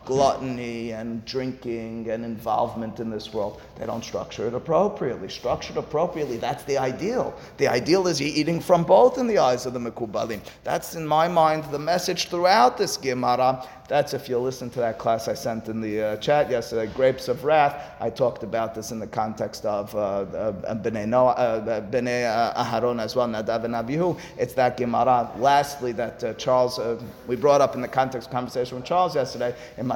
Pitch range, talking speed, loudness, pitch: 115-140 Hz, 190 wpm, -24 LUFS, 125 Hz